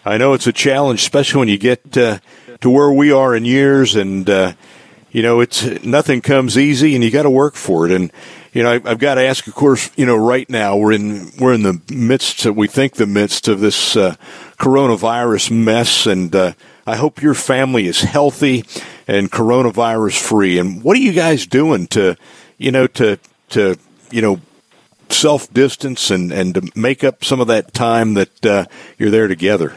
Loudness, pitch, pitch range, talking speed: -14 LUFS, 120 Hz, 105-135 Hz, 205 wpm